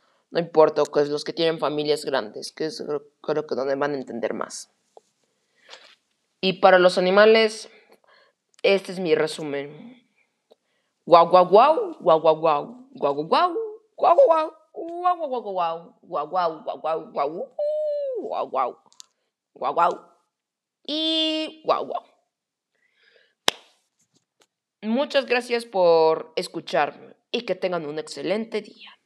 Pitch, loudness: 205 Hz, -22 LUFS